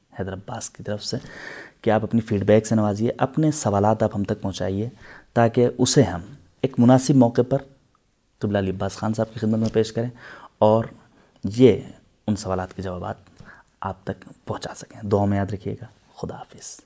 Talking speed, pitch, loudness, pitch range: 180 wpm, 110 Hz, -22 LUFS, 100-120 Hz